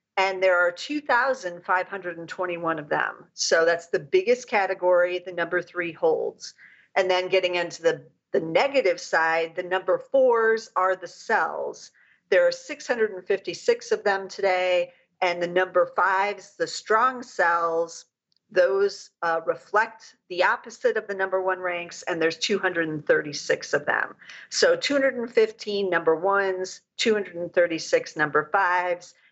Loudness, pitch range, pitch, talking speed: -24 LUFS, 175-235 Hz, 190 Hz, 130 wpm